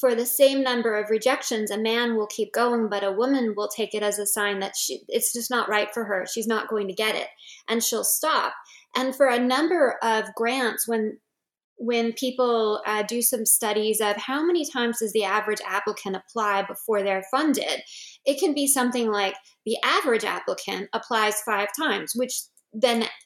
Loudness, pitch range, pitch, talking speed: -24 LUFS, 210-255 Hz, 225 Hz, 195 wpm